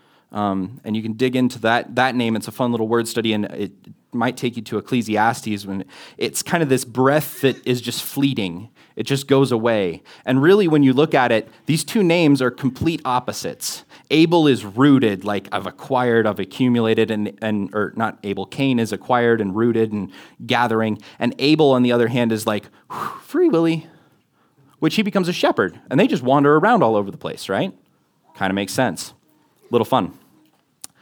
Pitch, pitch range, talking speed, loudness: 120 Hz, 110-135 Hz, 195 wpm, -19 LUFS